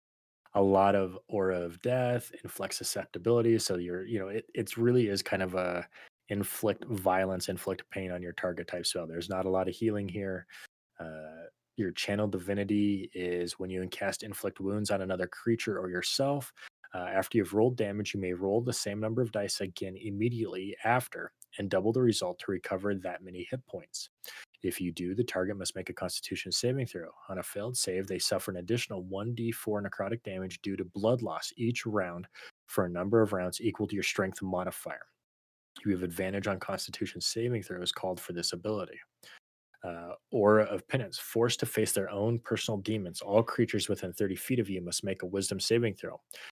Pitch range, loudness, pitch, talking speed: 90-110 Hz, -32 LUFS, 100 Hz, 190 wpm